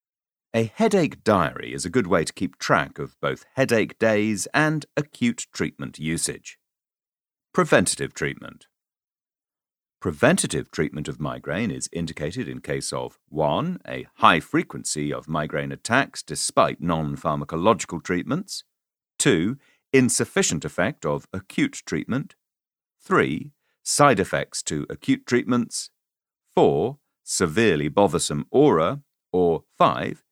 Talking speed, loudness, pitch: 115 wpm, -23 LUFS, 110 Hz